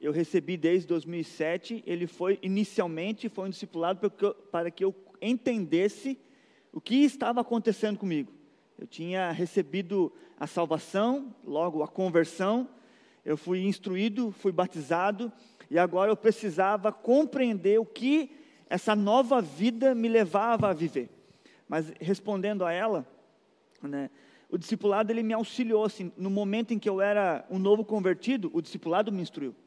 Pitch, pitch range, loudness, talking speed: 200 Hz, 175-225 Hz, -29 LUFS, 150 wpm